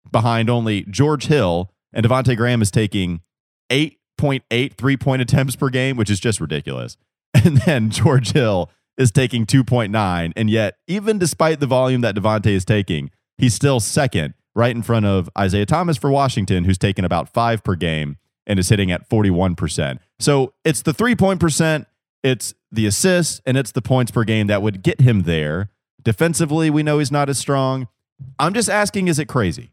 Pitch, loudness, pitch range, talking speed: 120 Hz, -18 LUFS, 100-140 Hz, 185 wpm